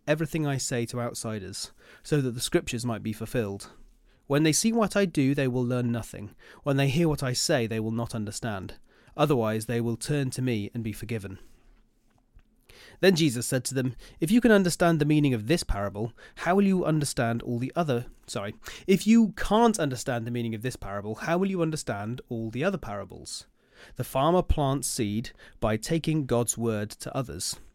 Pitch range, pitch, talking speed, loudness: 115-155 Hz, 125 Hz, 195 wpm, -27 LUFS